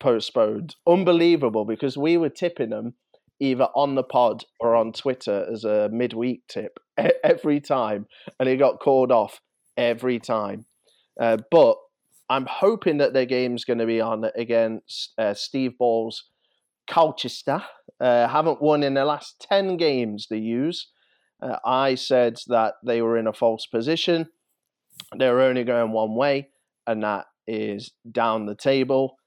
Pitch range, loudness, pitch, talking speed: 115-145 Hz, -23 LUFS, 125 Hz, 150 wpm